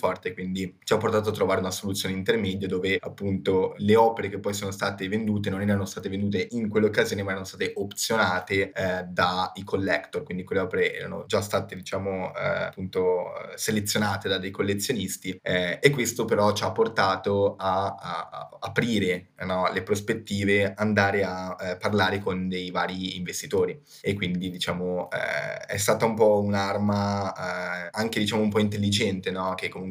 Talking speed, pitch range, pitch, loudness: 175 wpm, 95-105 Hz, 100 Hz, -26 LUFS